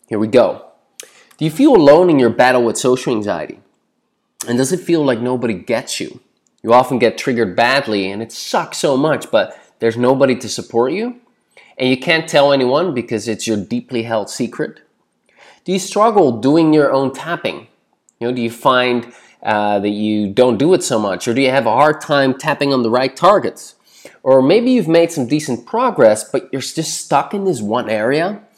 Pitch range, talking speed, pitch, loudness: 115-160 Hz, 200 wpm, 130 Hz, -15 LUFS